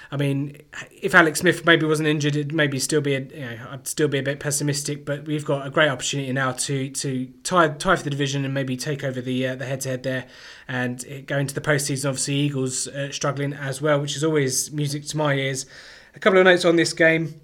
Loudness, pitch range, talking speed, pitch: -22 LUFS, 135-150 Hz, 240 wpm, 140 Hz